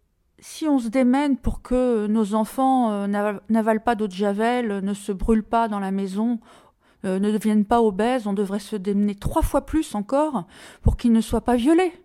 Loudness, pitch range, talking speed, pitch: -22 LUFS, 210-250 Hz, 200 wpm, 225 Hz